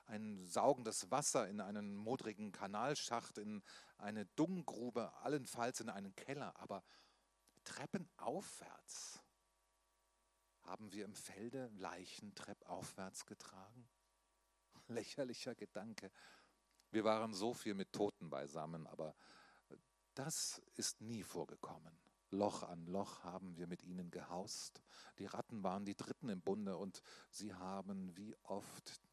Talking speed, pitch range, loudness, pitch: 120 wpm, 95-110 Hz, -46 LUFS, 100 Hz